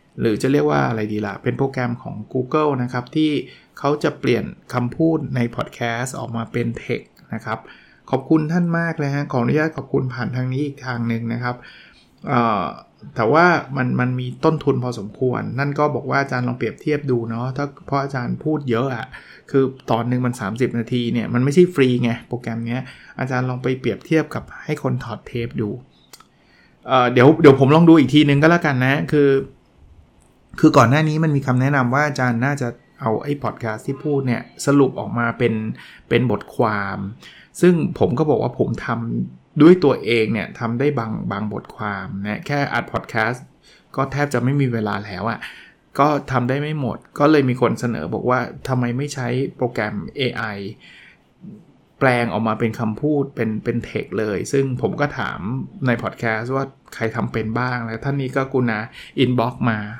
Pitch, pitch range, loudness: 125 Hz, 115-140 Hz, -20 LUFS